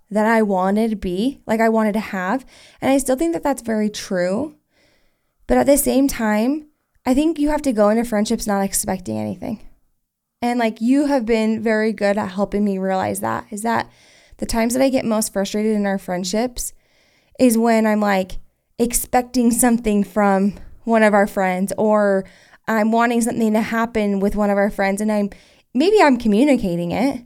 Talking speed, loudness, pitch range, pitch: 190 wpm, -19 LUFS, 200-245 Hz, 220 Hz